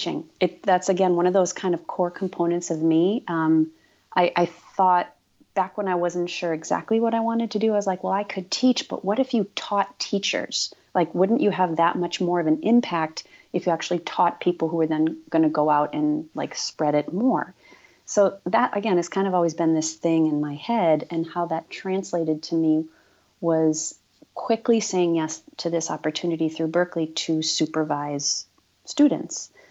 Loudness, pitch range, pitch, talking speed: -23 LUFS, 160-195 Hz, 175 Hz, 200 wpm